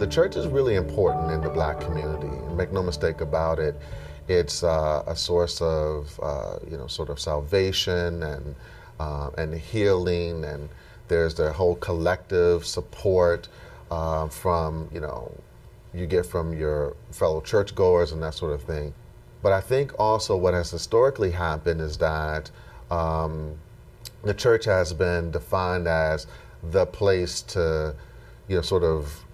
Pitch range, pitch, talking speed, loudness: 75-90 Hz, 80 Hz, 150 wpm, -25 LUFS